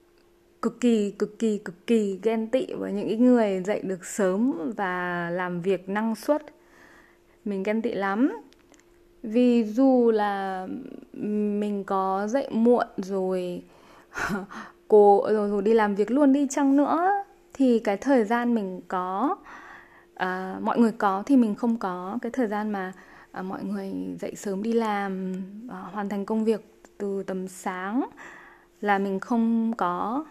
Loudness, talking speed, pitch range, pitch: -25 LUFS, 155 wpm, 195-245 Hz, 210 Hz